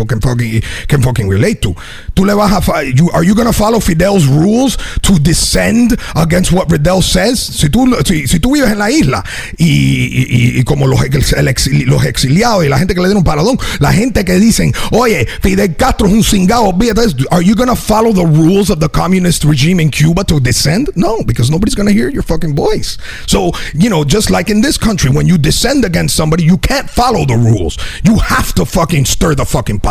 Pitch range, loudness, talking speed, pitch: 140-205 Hz, -11 LUFS, 175 wpm, 170 Hz